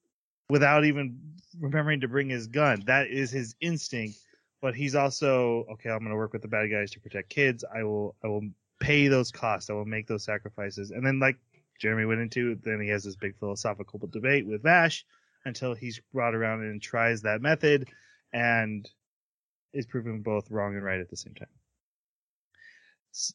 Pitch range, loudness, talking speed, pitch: 105-140 Hz, -28 LUFS, 185 wpm, 115 Hz